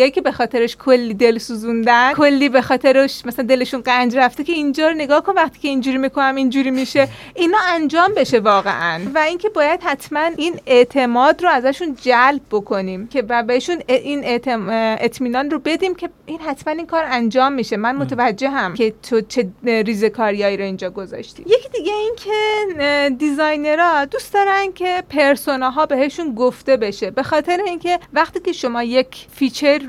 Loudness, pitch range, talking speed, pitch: -17 LUFS, 240-315 Hz, 170 wpm, 270 Hz